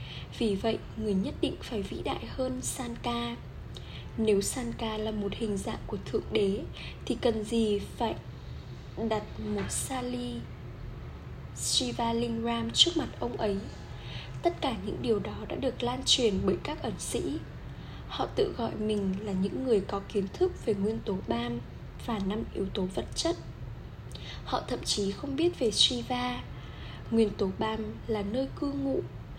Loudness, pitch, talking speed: -31 LUFS, 205 Hz, 160 wpm